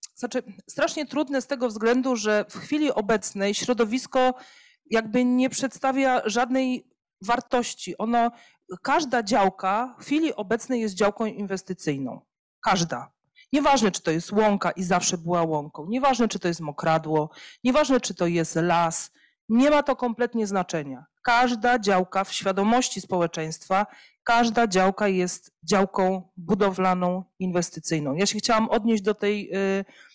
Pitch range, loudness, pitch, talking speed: 185-245 Hz, -24 LUFS, 210 Hz, 135 wpm